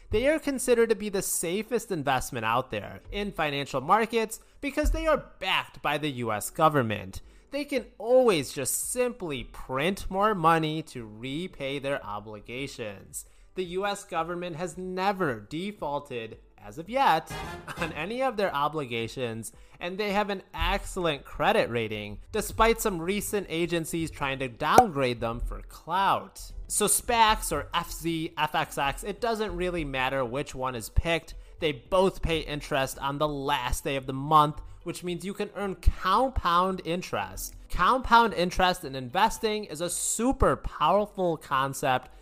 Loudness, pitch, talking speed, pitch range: -28 LUFS, 165 Hz, 150 wpm, 135-200 Hz